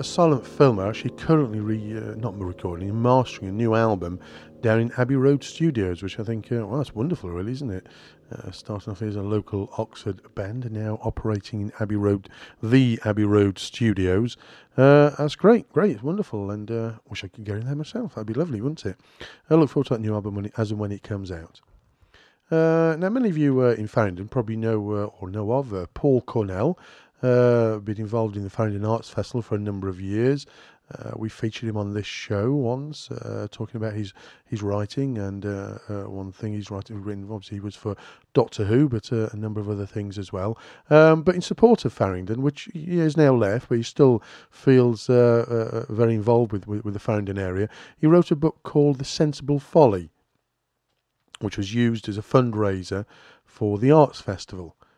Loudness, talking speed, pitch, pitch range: -23 LUFS, 205 wpm, 110 Hz, 105-130 Hz